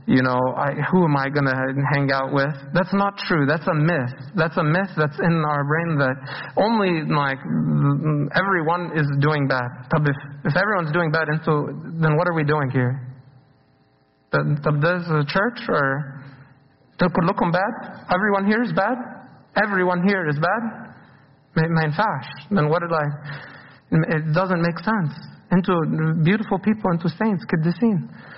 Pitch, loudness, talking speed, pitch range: 160 Hz, -21 LUFS, 160 wpm, 140-185 Hz